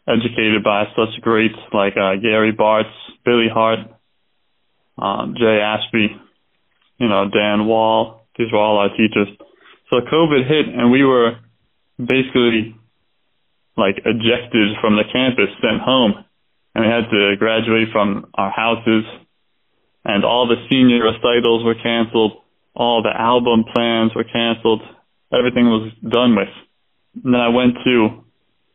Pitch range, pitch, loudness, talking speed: 110-120 Hz, 115 Hz, -16 LUFS, 140 wpm